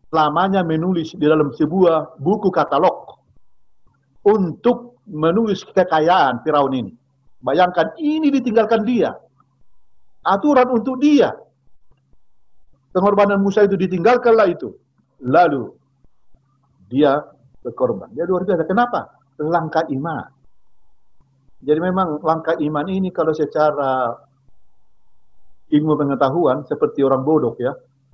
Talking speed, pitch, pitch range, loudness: 100 wpm, 160 Hz, 140-190 Hz, -18 LUFS